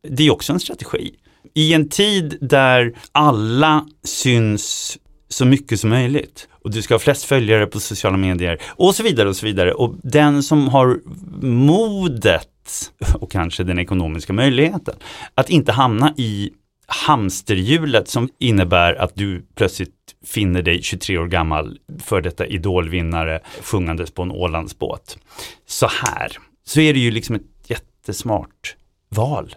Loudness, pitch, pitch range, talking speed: -18 LUFS, 115 Hz, 95-145 Hz, 145 wpm